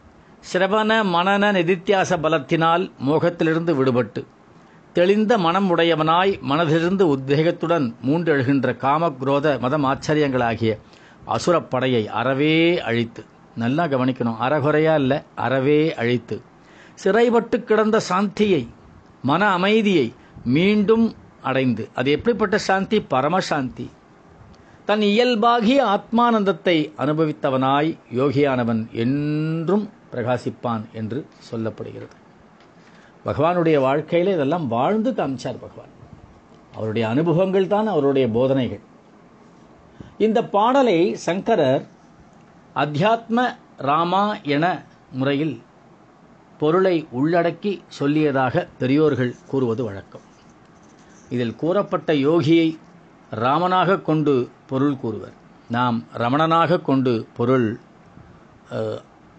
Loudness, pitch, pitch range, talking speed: -20 LUFS, 155 Hz, 130-185 Hz, 80 wpm